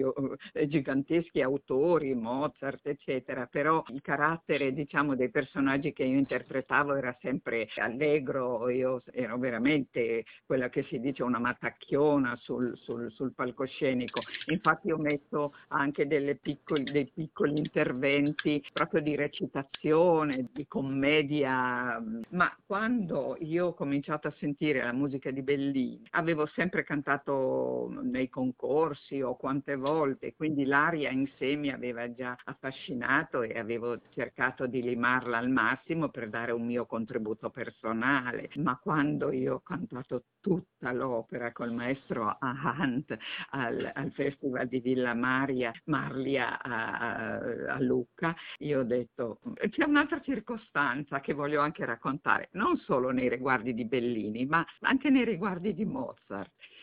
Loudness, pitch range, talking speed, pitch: -31 LUFS, 125-155 Hz, 135 wpm, 140 Hz